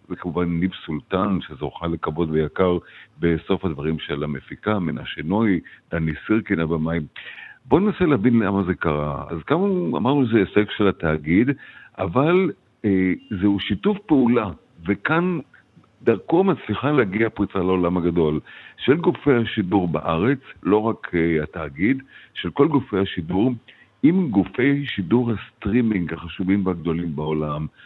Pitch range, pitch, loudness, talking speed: 85-115 Hz, 95 Hz, -22 LUFS, 125 wpm